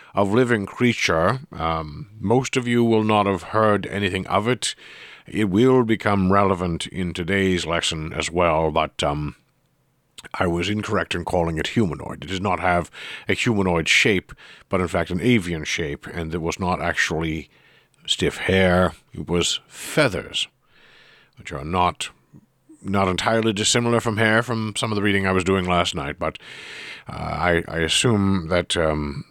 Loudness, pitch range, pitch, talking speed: -21 LUFS, 85-110 Hz, 95 Hz, 165 wpm